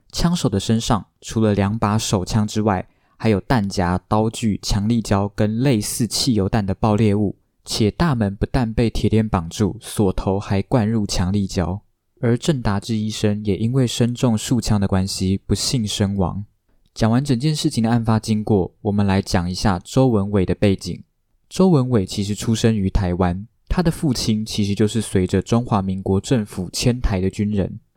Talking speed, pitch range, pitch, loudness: 265 characters per minute, 95-115 Hz, 105 Hz, -20 LUFS